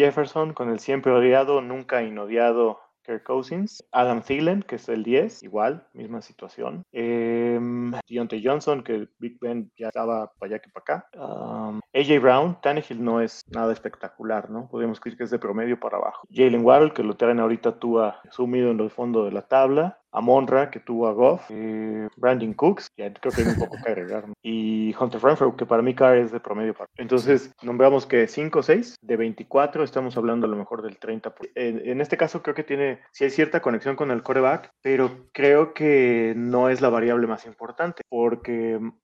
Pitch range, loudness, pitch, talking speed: 115-135 Hz, -23 LUFS, 120 Hz, 200 wpm